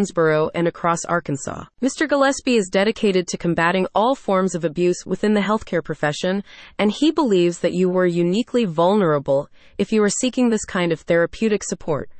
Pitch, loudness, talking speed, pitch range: 185 Hz, -20 LUFS, 165 wpm, 170-215 Hz